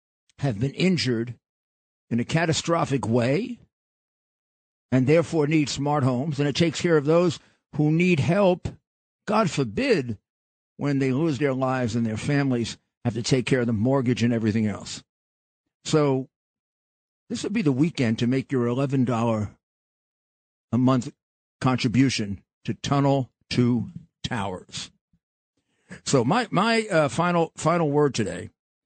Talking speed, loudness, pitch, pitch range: 135 wpm, -24 LUFS, 135 Hz, 120-155 Hz